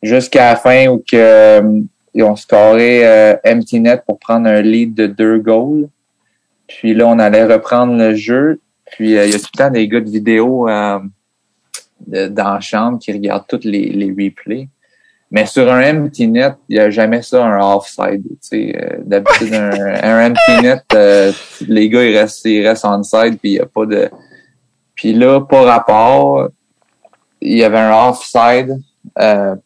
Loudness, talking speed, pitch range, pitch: -10 LUFS, 185 wpm, 105-120 Hz, 110 Hz